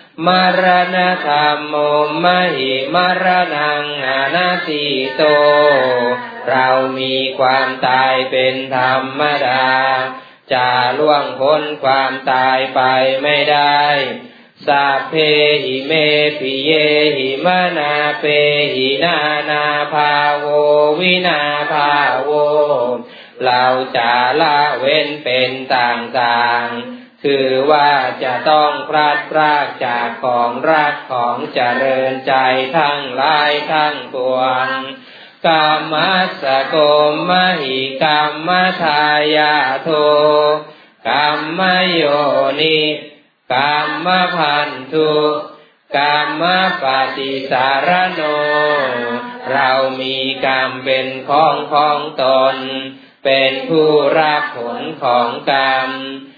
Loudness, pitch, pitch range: -14 LUFS, 145 Hz, 130-150 Hz